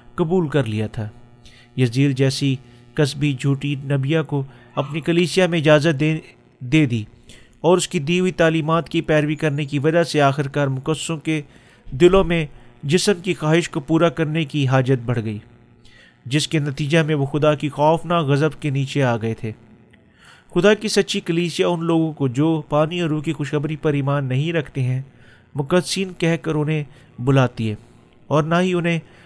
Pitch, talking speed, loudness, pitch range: 150 Hz, 175 wpm, -20 LUFS, 130-165 Hz